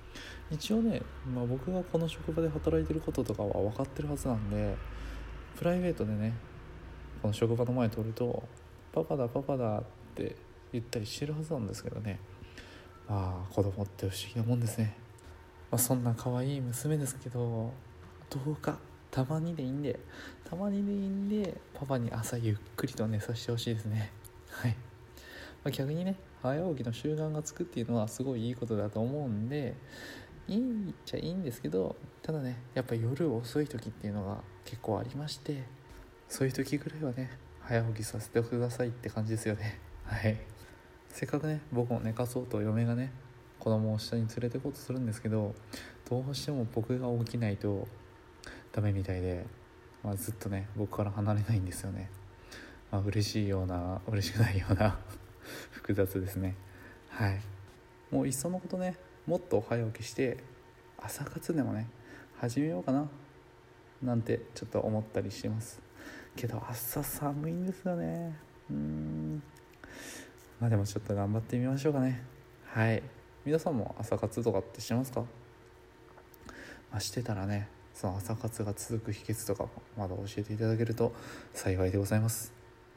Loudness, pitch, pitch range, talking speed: -35 LUFS, 115 Hz, 105-130 Hz, 340 characters per minute